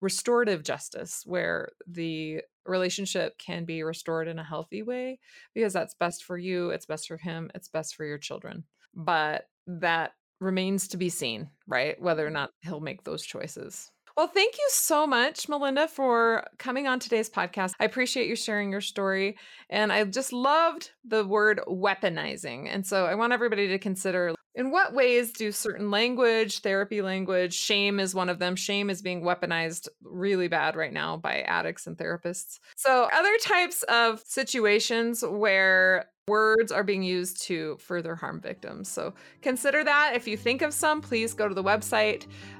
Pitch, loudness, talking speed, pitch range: 205 Hz, -27 LUFS, 175 wpm, 180-240 Hz